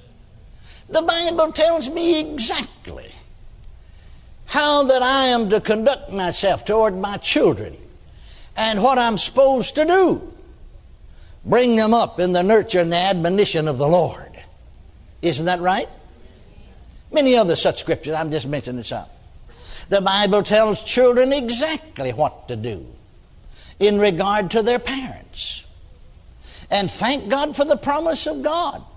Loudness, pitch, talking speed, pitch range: -18 LUFS, 220 Hz, 135 wpm, 175-280 Hz